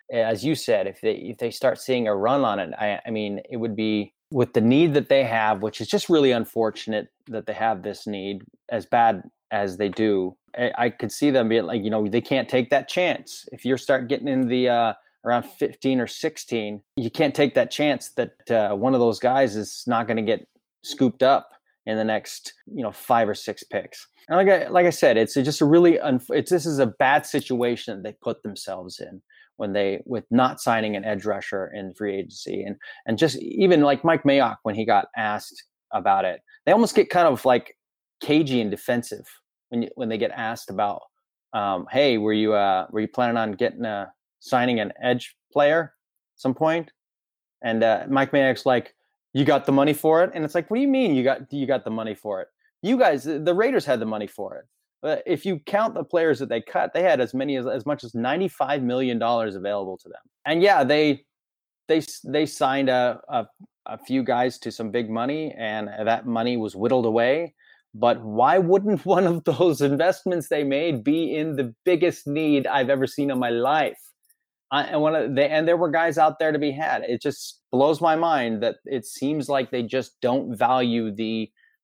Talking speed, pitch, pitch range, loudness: 220 wpm, 130 Hz, 115-155 Hz, -23 LUFS